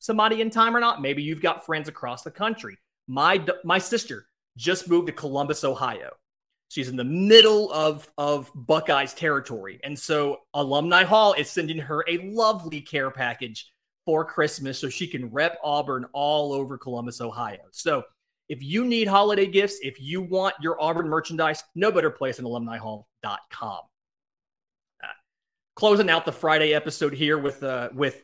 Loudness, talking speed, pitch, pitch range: -23 LUFS, 165 wpm, 155 Hz, 140-185 Hz